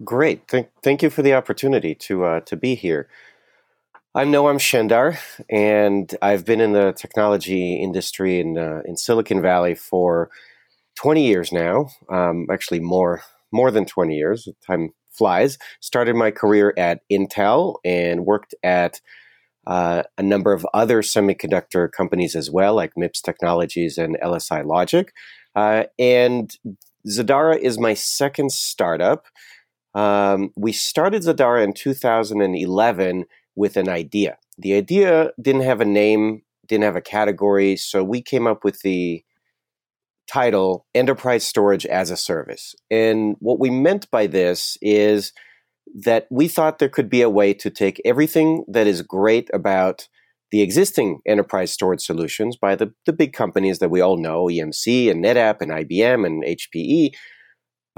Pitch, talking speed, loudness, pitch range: 105 Hz, 150 wpm, -19 LUFS, 95-125 Hz